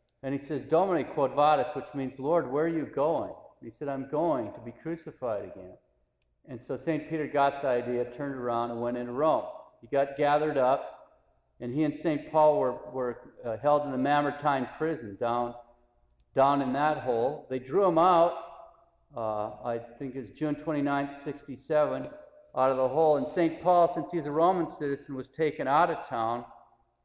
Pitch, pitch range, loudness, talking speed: 140 Hz, 120-155 Hz, -29 LUFS, 185 wpm